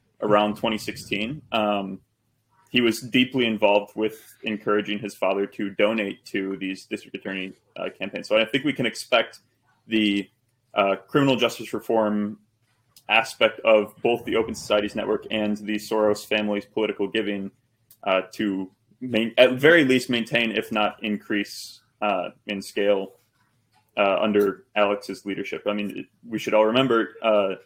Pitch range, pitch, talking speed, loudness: 100-115 Hz, 110 Hz, 145 wpm, -24 LUFS